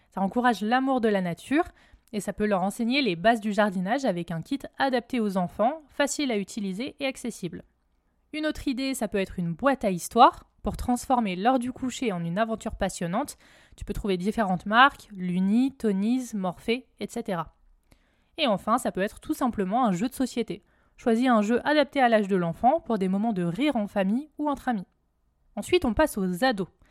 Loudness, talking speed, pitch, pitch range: -26 LUFS, 195 wpm, 225 Hz, 195-260 Hz